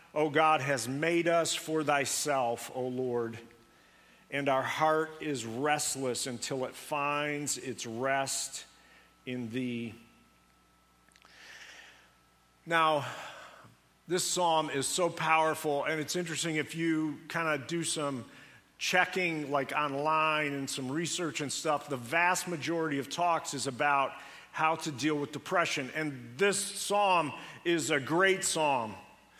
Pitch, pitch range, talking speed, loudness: 150 Hz, 135-165 Hz, 130 wpm, -31 LUFS